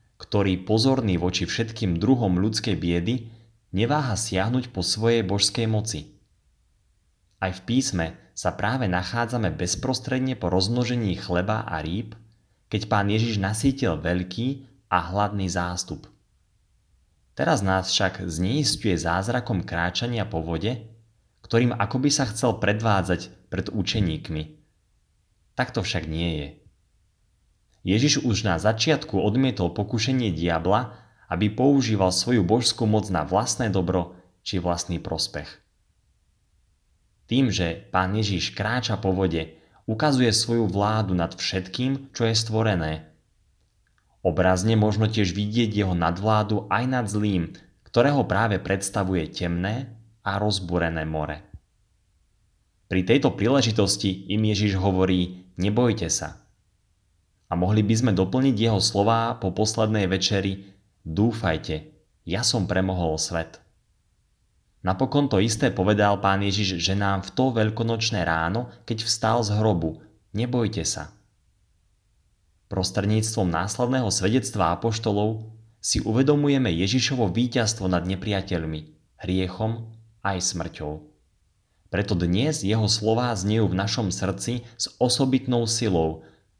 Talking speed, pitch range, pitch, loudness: 115 wpm, 90-115 Hz, 100 Hz, -24 LUFS